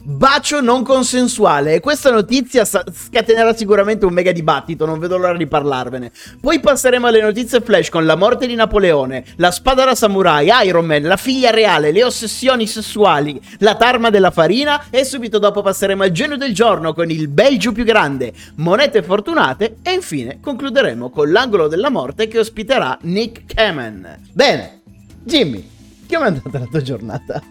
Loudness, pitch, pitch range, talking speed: -14 LUFS, 215 Hz, 160-245 Hz, 165 wpm